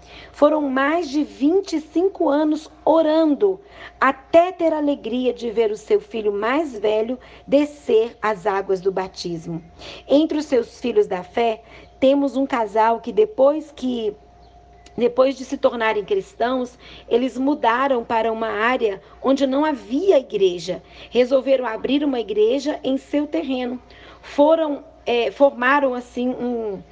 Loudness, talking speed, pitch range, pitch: -20 LUFS, 135 wpm, 225-295 Hz, 260 Hz